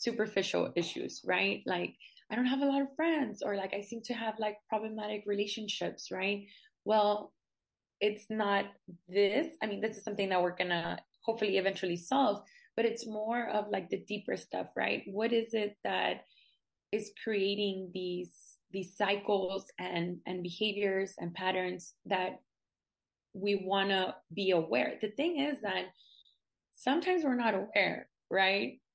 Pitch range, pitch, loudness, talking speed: 190-220 Hz, 205 Hz, -34 LUFS, 155 wpm